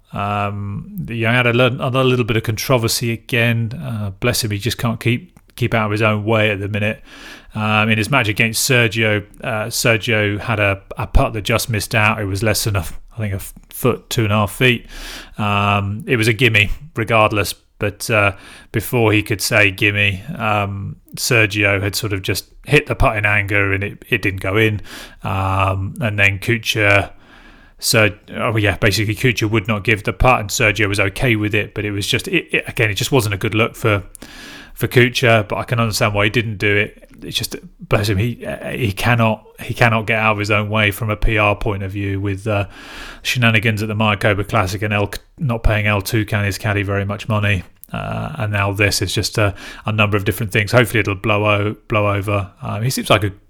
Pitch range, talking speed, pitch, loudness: 100-115 Hz, 215 wpm, 110 Hz, -17 LUFS